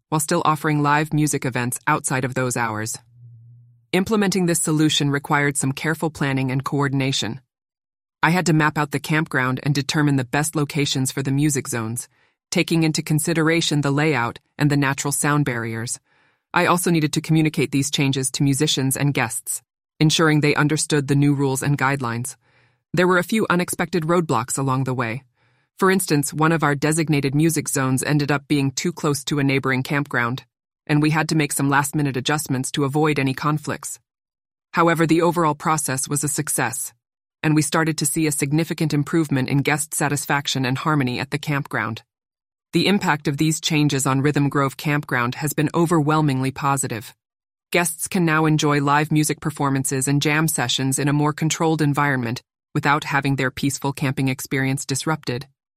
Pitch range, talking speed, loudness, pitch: 135-155 Hz, 175 wpm, -20 LUFS, 145 Hz